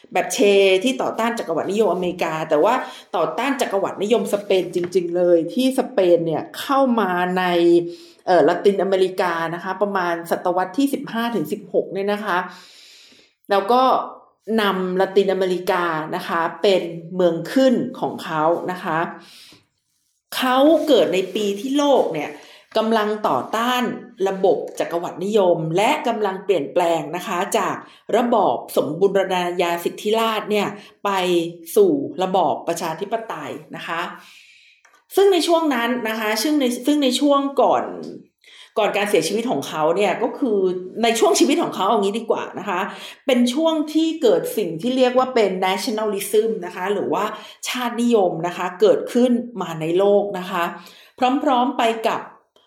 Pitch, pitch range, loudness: 200 Hz, 180-245 Hz, -20 LUFS